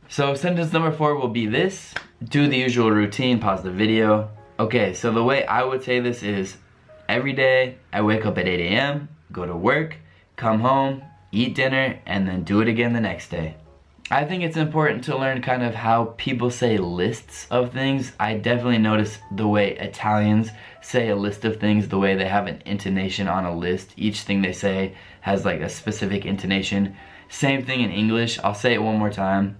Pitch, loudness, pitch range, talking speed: 110 Hz, -22 LUFS, 100-125 Hz, 200 wpm